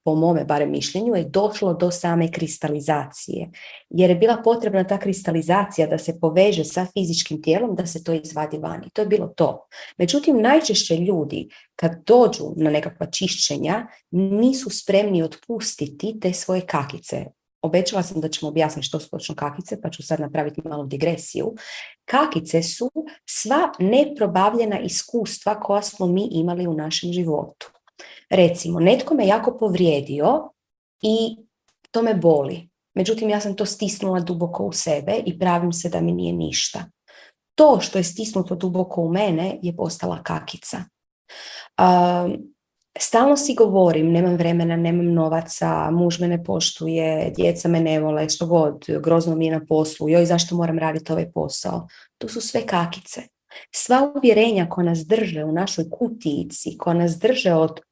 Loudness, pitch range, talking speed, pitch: -20 LUFS, 160-205 Hz, 155 wpm, 175 Hz